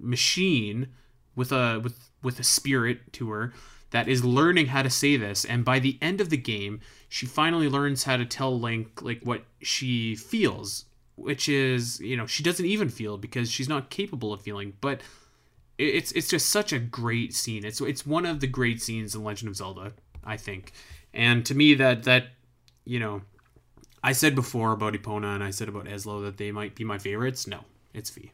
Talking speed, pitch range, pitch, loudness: 200 wpm, 105-135 Hz, 120 Hz, -26 LUFS